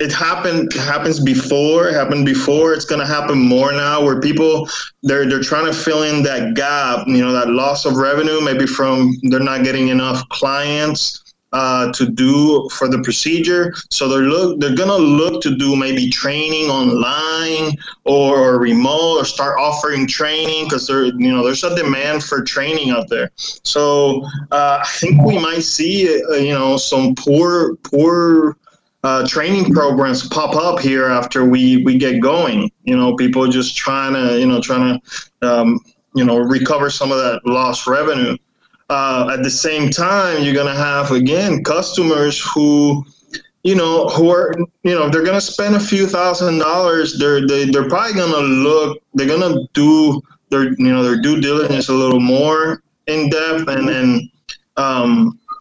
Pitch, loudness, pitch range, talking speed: 145 Hz, -15 LUFS, 130-160 Hz, 170 wpm